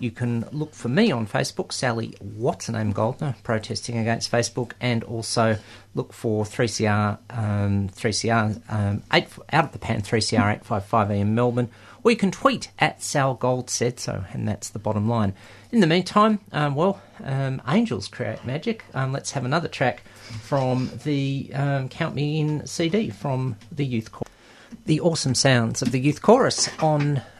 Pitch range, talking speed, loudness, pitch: 110-140 Hz, 165 wpm, -24 LUFS, 120 Hz